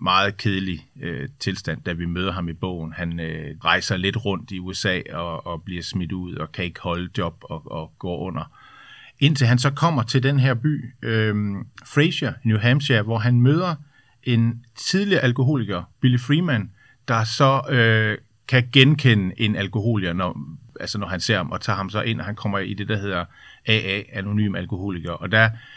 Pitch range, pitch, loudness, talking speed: 95-125 Hz, 110 Hz, -22 LUFS, 190 wpm